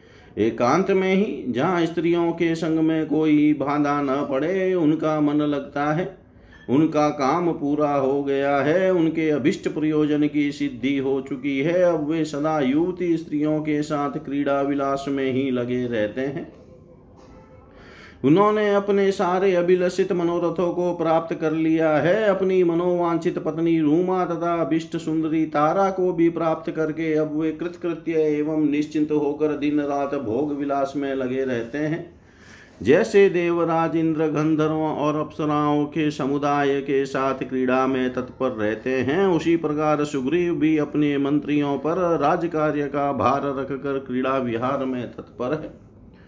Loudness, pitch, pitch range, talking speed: -22 LUFS, 150 Hz, 140-170 Hz, 145 wpm